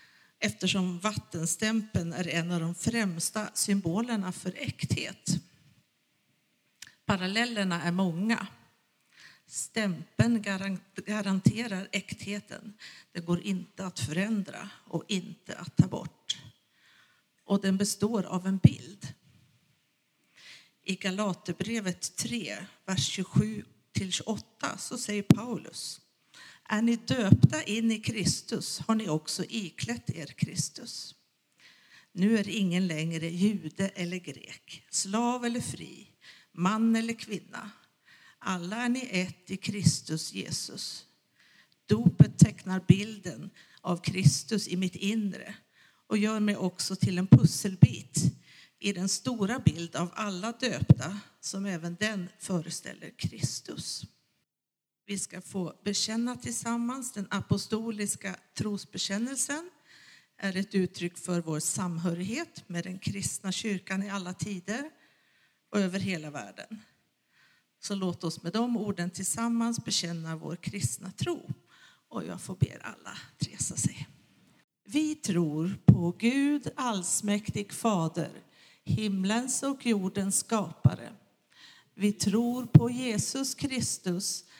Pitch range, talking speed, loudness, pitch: 175-215 Hz, 110 wpm, -30 LUFS, 195 Hz